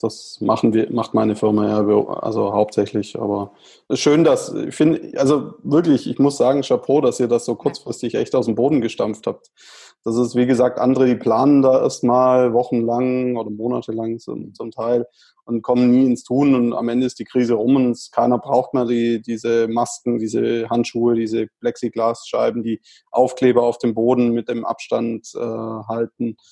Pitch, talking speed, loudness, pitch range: 120 Hz, 180 wpm, -19 LUFS, 115-125 Hz